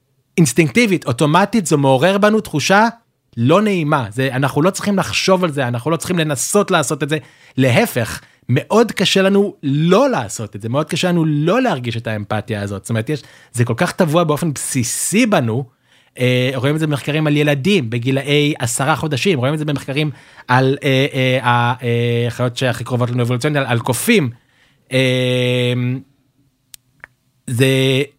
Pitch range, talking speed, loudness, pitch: 125-165 Hz, 160 wpm, -16 LUFS, 140 Hz